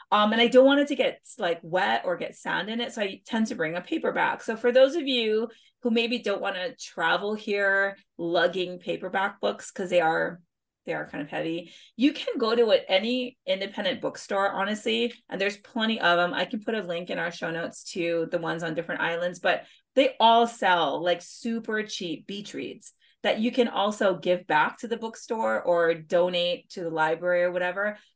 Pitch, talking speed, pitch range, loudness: 200 Hz, 210 wpm, 175-235 Hz, -26 LUFS